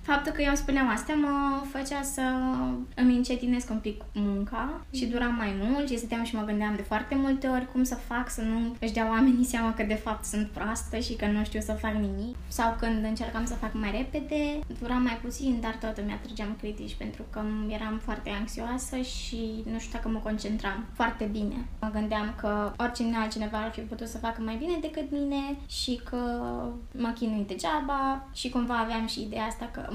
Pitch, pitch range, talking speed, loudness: 230 Hz, 215-255 Hz, 200 wpm, -30 LUFS